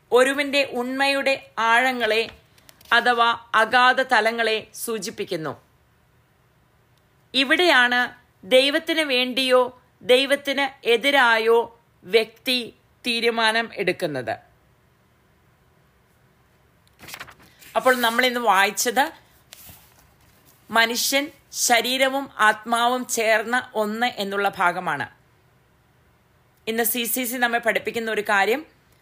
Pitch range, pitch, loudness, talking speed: 215-255 Hz, 235 Hz, -20 LUFS, 70 wpm